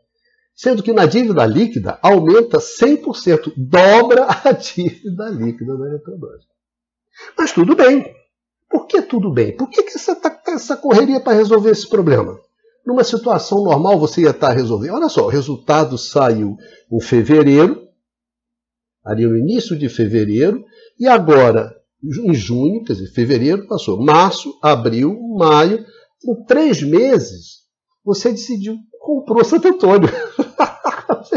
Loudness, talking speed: -14 LUFS, 140 wpm